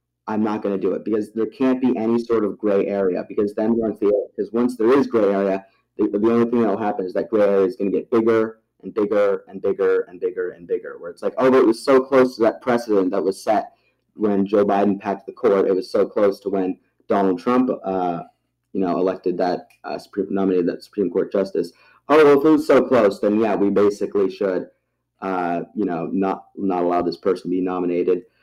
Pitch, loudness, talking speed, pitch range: 110 Hz, -20 LUFS, 240 wpm, 95-130 Hz